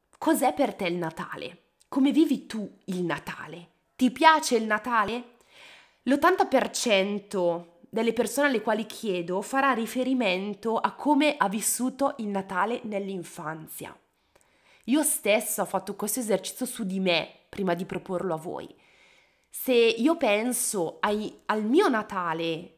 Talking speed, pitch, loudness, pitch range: 130 wpm, 215 Hz, -26 LUFS, 190-255 Hz